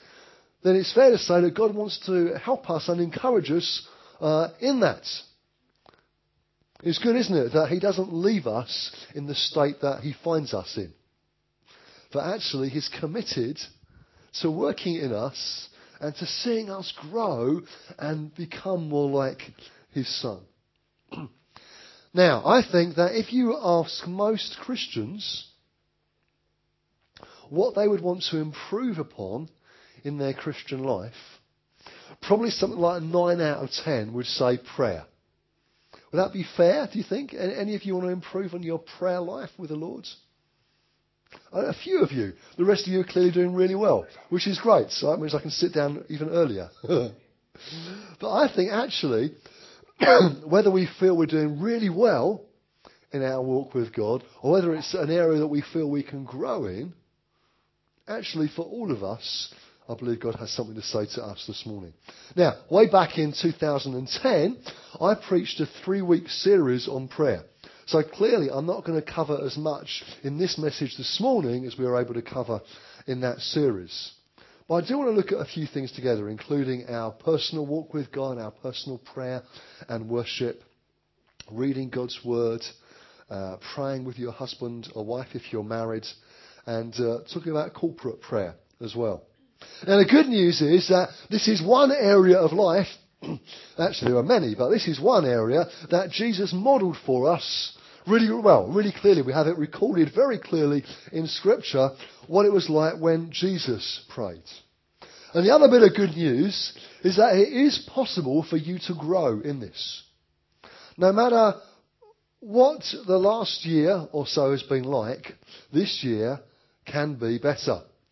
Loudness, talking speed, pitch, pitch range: -25 LUFS, 170 wpm, 165 Hz, 135-195 Hz